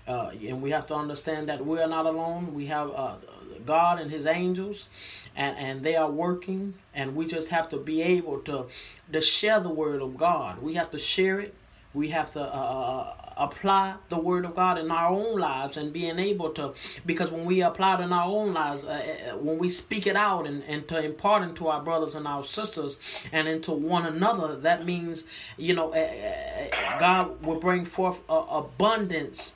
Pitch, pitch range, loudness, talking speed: 165 Hz, 155-180 Hz, -28 LUFS, 205 wpm